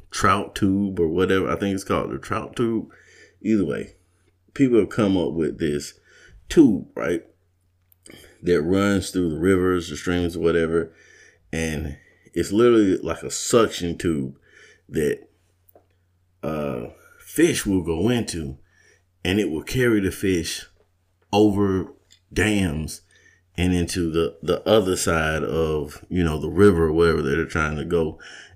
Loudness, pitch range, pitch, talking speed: -22 LUFS, 80-95 Hz, 90 Hz, 145 wpm